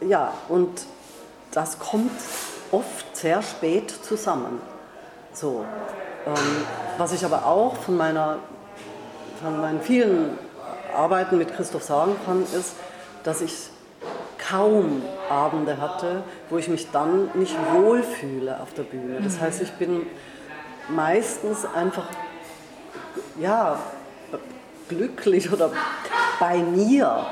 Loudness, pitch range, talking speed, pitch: -24 LUFS, 165-240 Hz, 110 wpm, 180 Hz